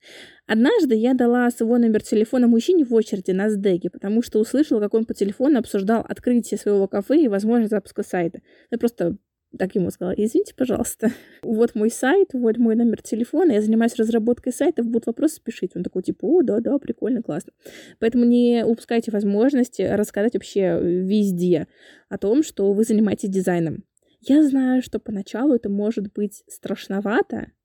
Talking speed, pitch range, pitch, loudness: 165 wpm, 205-245 Hz, 225 Hz, -21 LUFS